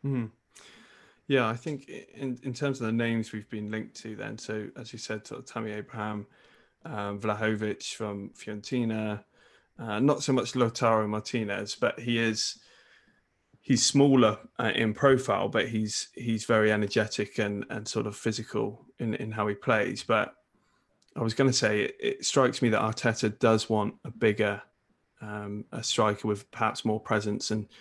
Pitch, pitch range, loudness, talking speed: 110 Hz, 105-120 Hz, -29 LUFS, 170 wpm